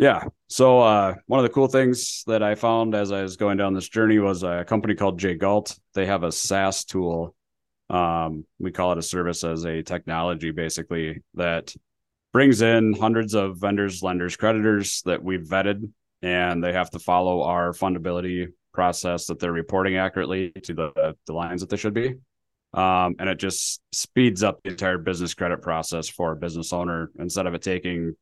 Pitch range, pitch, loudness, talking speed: 85-100 Hz, 90 Hz, -23 LUFS, 185 wpm